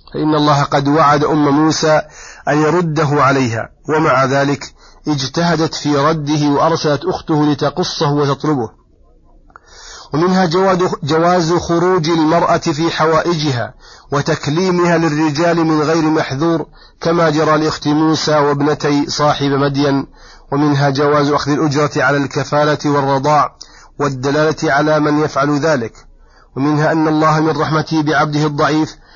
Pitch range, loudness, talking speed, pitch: 145-160 Hz, -14 LUFS, 115 wpm, 150 Hz